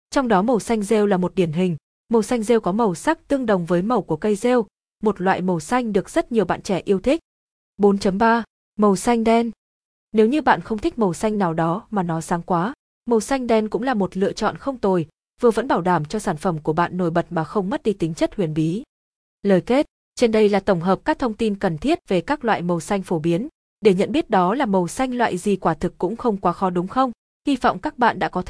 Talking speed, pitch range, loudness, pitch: 255 wpm, 180-235 Hz, -21 LUFS, 205 Hz